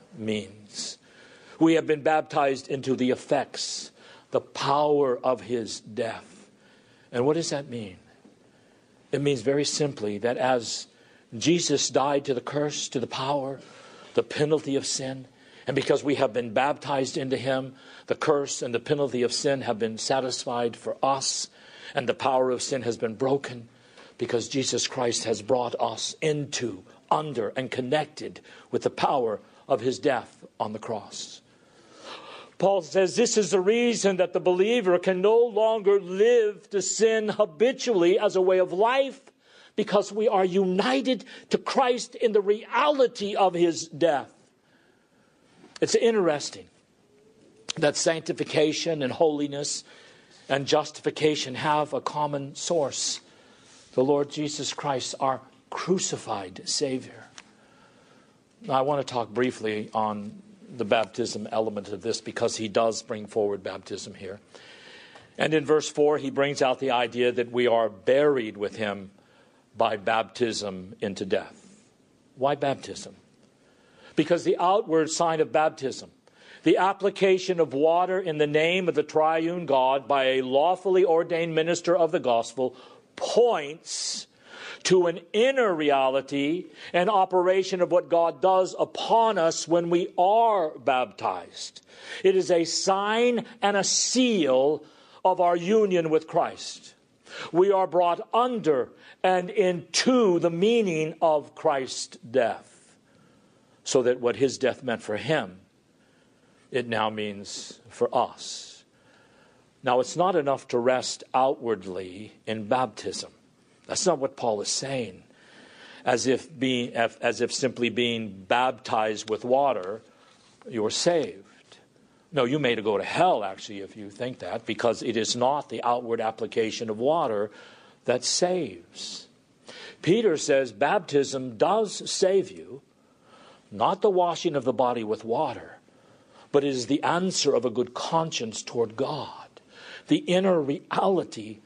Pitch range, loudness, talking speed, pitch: 125-185 Hz, -25 LUFS, 140 wpm, 150 Hz